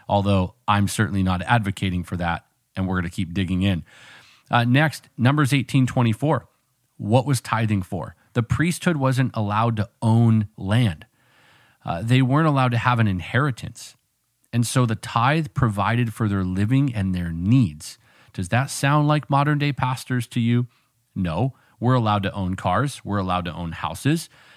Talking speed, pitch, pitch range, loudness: 165 wpm, 120 Hz, 100-130 Hz, -22 LUFS